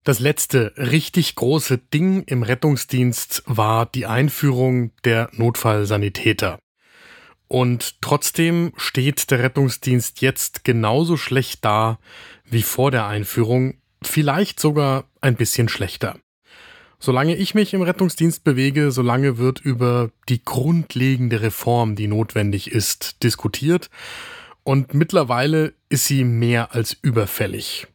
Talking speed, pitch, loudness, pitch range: 115 wpm, 130 Hz, -19 LUFS, 115-150 Hz